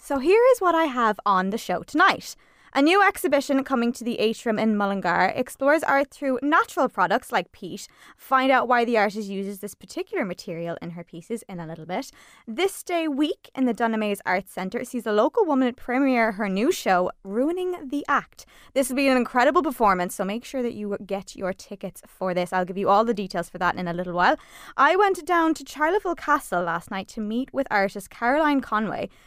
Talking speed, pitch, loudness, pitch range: 210 wpm, 235 Hz, -23 LUFS, 195-285 Hz